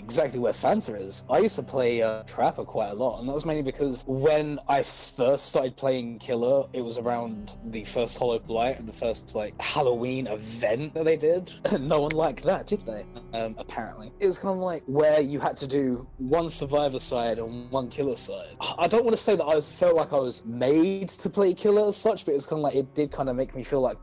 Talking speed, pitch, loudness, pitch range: 240 wpm, 140 Hz, -26 LUFS, 125-160 Hz